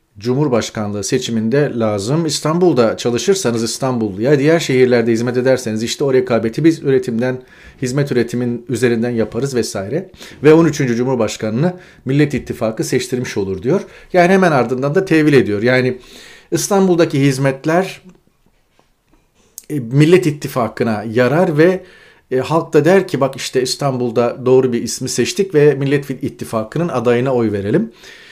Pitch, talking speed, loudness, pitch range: 130 Hz, 125 wpm, -15 LUFS, 120-155 Hz